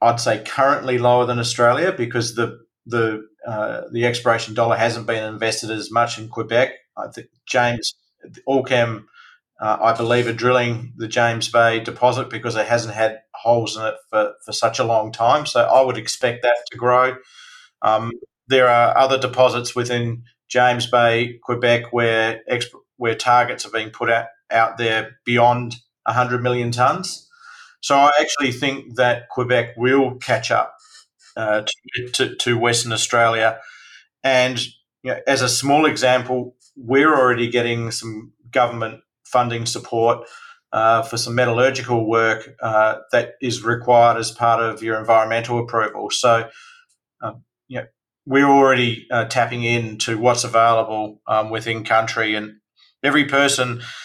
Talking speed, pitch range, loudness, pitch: 150 wpm, 115-125 Hz, -19 LUFS, 120 Hz